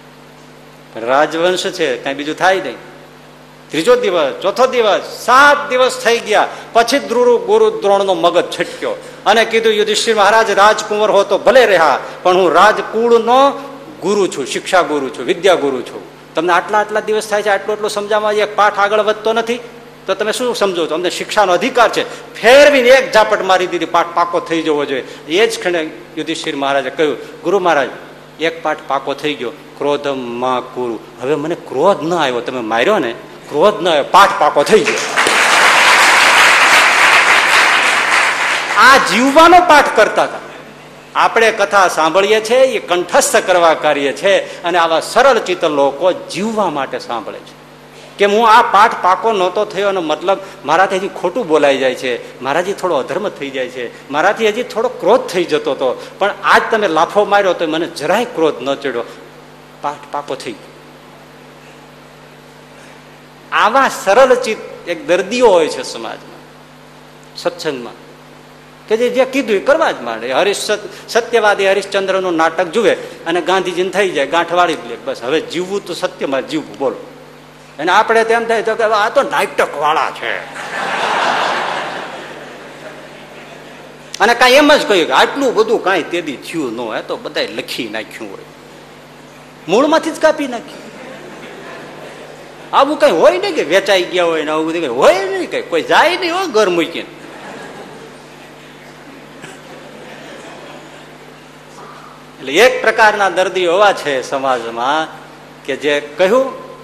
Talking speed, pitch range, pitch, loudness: 150 wpm, 170-255 Hz, 200 Hz, -13 LUFS